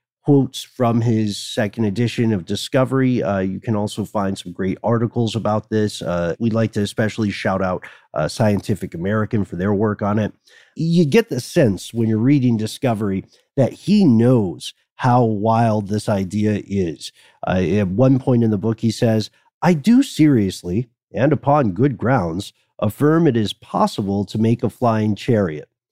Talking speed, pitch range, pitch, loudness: 170 wpm, 105-125 Hz, 110 Hz, -19 LUFS